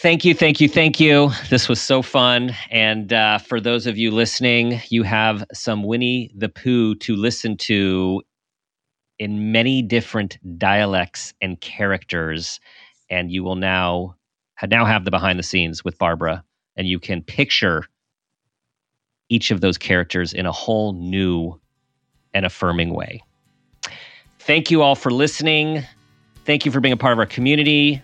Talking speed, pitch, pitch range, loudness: 155 wpm, 110 Hz, 95-125 Hz, -18 LUFS